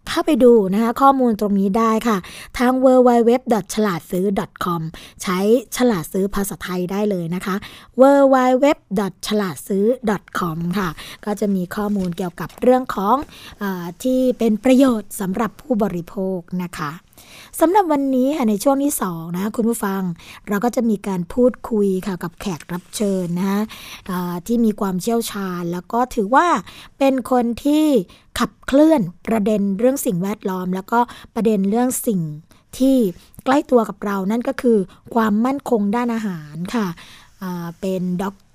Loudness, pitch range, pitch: -19 LUFS, 190-245 Hz, 210 Hz